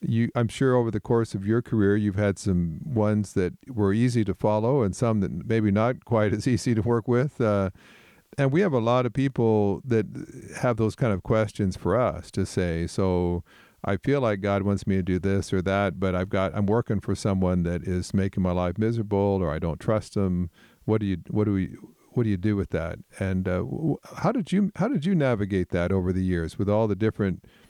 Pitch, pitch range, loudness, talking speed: 105 Hz, 95-120 Hz, -25 LUFS, 230 wpm